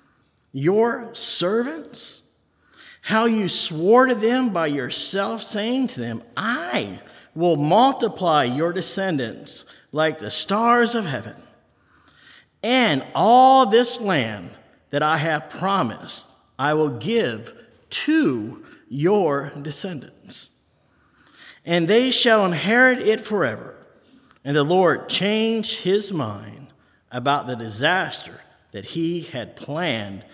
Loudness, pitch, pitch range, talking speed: -20 LUFS, 175 Hz, 140-230 Hz, 110 wpm